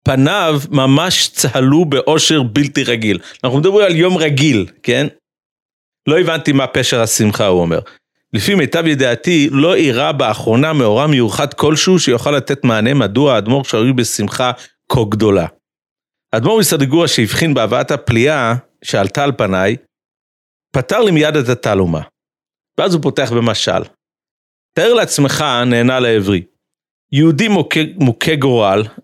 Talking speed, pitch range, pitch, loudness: 125 wpm, 115-155 Hz, 135 Hz, -13 LUFS